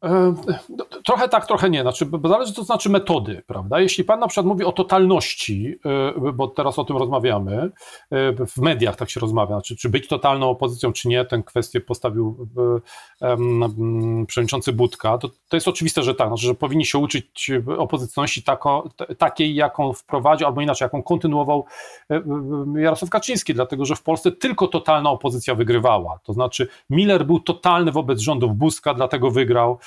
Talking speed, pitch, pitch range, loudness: 165 wpm, 140 Hz, 125-165 Hz, -20 LUFS